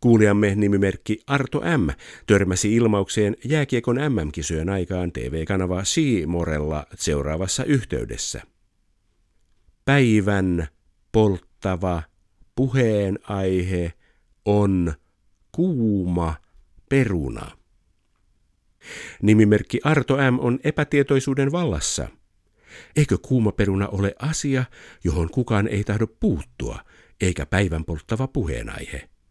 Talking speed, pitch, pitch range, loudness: 80 wpm, 100 Hz, 85-115 Hz, -22 LUFS